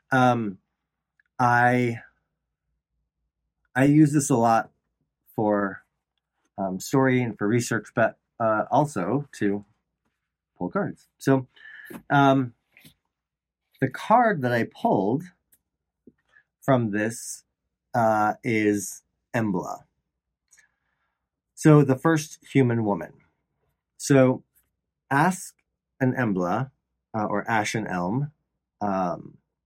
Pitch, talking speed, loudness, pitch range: 115 Hz, 90 wpm, -24 LUFS, 100-135 Hz